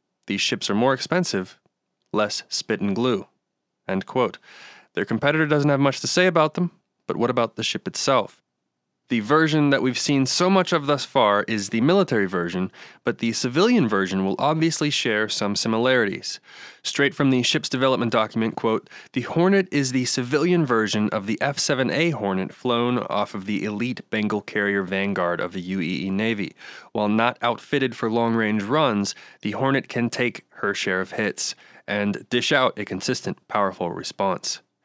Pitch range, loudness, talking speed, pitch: 105-145 Hz, -23 LUFS, 170 wpm, 120 Hz